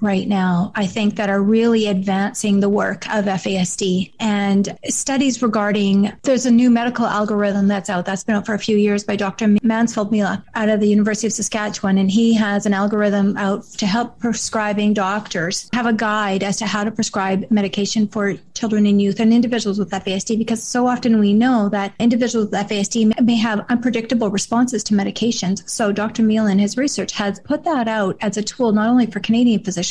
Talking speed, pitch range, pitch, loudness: 200 wpm, 200-225 Hz, 210 Hz, -18 LUFS